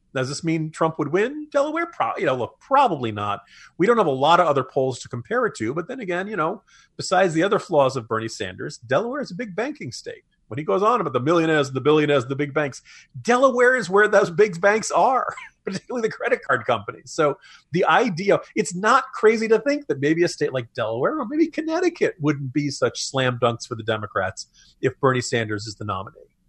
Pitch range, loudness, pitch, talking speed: 135-225 Hz, -22 LUFS, 165 Hz, 220 wpm